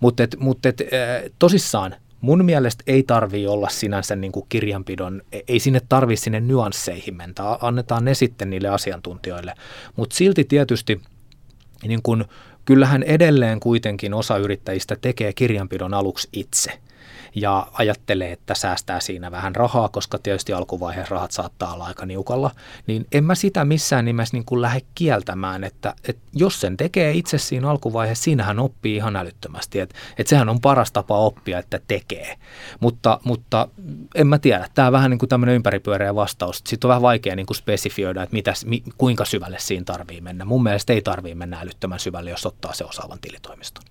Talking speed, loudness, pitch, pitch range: 165 wpm, -20 LUFS, 110 Hz, 100-125 Hz